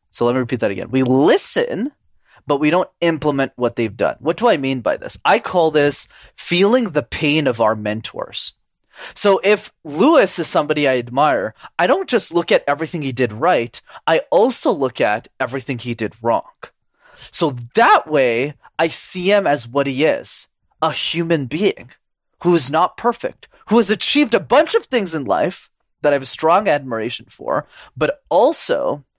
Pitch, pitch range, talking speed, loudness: 150 Hz, 130-180 Hz, 185 wpm, -17 LUFS